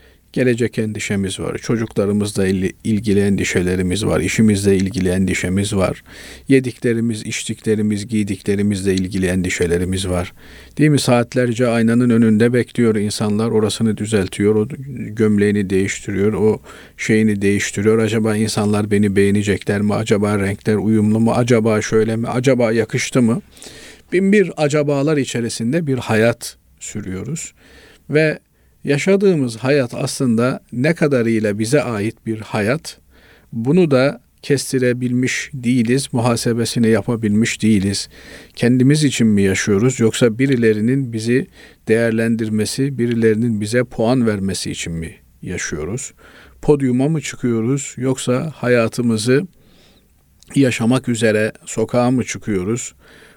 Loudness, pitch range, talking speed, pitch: -17 LUFS, 100-125 Hz, 110 wpm, 110 Hz